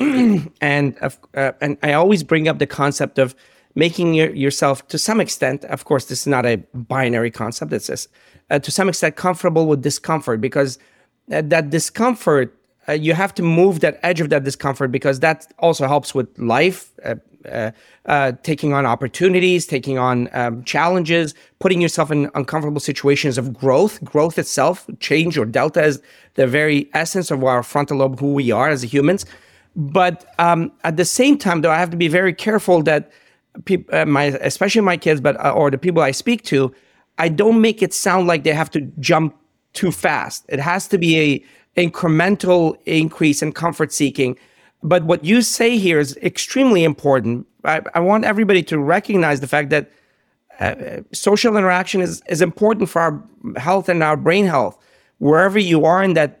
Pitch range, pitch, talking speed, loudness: 140-180 Hz, 160 Hz, 185 wpm, -17 LUFS